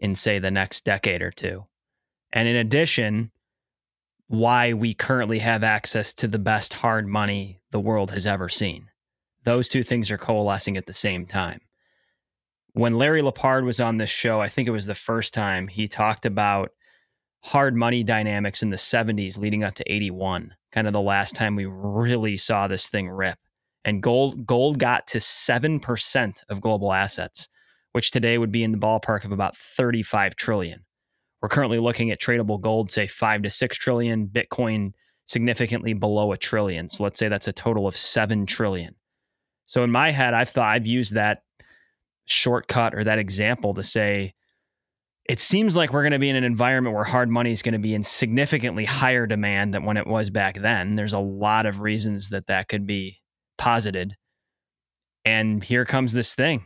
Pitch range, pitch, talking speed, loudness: 100-120 Hz, 110 Hz, 185 wpm, -22 LUFS